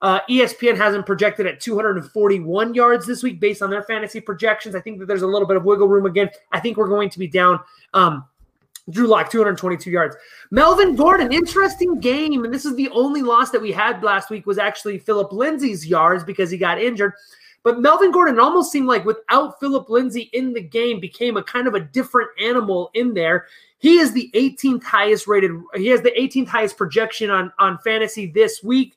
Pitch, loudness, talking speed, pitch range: 220 Hz, -18 LUFS, 205 wpm, 200-250 Hz